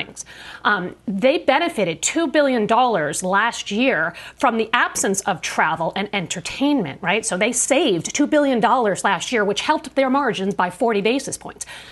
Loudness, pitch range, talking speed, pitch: -19 LUFS, 200-265 Hz, 150 wpm, 230 Hz